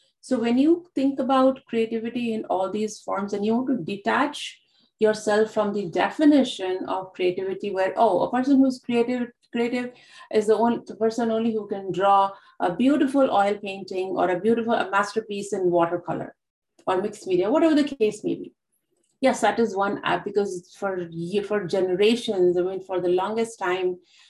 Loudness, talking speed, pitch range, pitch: -24 LUFS, 175 wpm, 195-245 Hz, 215 Hz